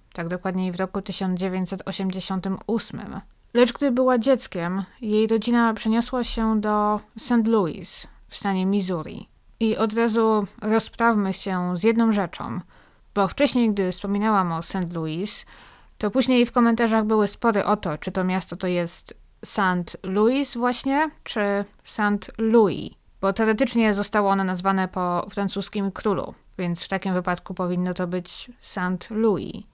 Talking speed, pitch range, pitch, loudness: 140 wpm, 185-225 Hz, 205 Hz, -23 LUFS